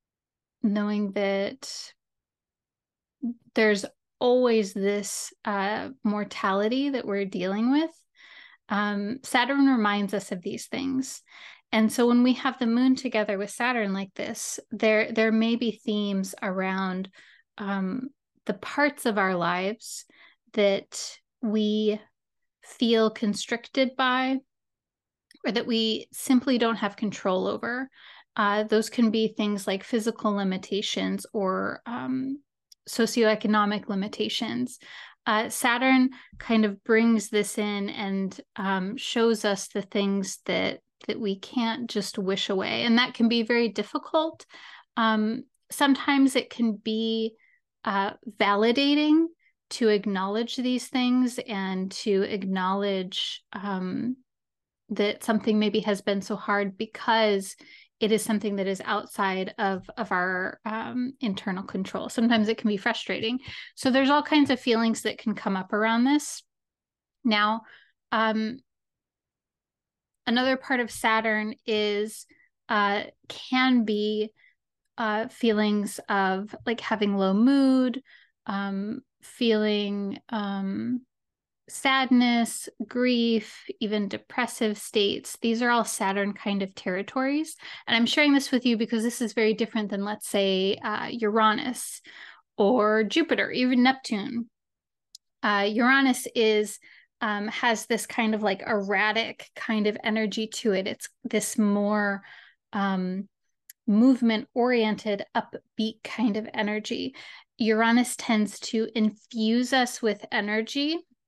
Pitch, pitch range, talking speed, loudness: 220 Hz, 205-245 Hz, 125 wpm, -26 LUFS